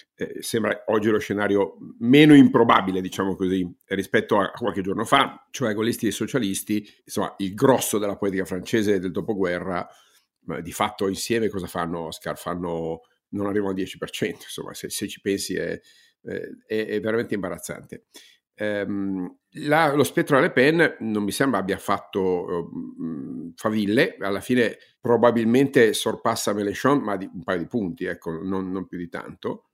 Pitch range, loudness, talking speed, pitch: 95-110 Hz, -23 LUFS, 160 wpm, 100 Hz